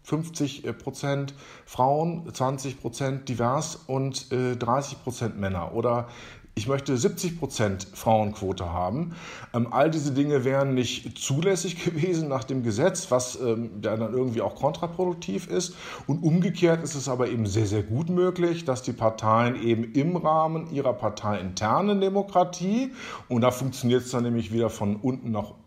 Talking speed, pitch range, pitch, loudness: 145 wpm, 115-160 Hz, 130 Hz, -26 LUFS